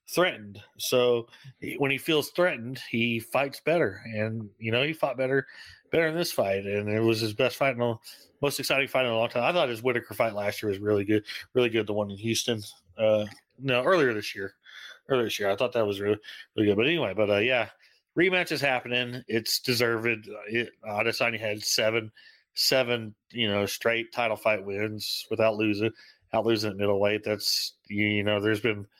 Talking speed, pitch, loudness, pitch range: 205 wpm, 115 Hz, -27 LUFS, 105-125 Hz